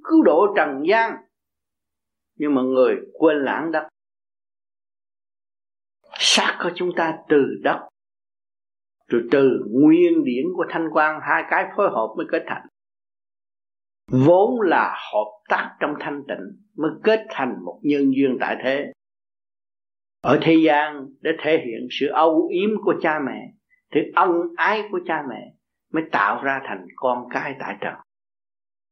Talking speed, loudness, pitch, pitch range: 145 wpm, -20 LUFS, 135 Hz, 100-160 Hz